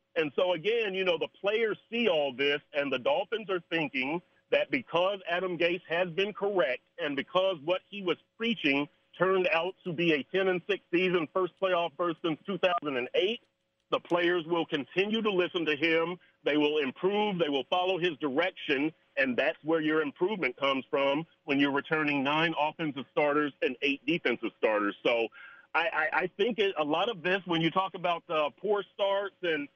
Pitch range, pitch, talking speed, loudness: 150-190 Hz, 175 Hz, 190 wpm, -29 LUFS